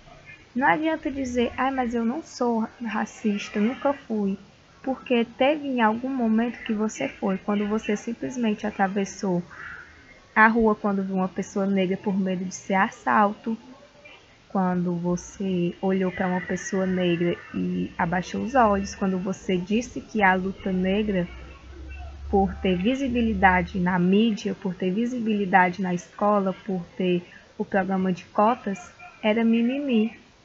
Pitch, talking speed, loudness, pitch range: 200 Hz, 140 wpm, -25 LUFS, 185-230 Hz